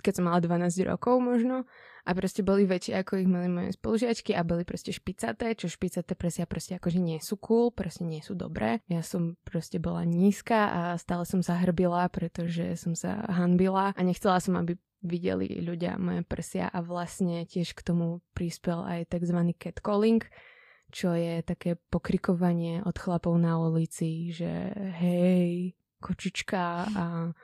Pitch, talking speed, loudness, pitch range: 175 Hz, 155 wpm, -29 LUFS, 170-190 Hz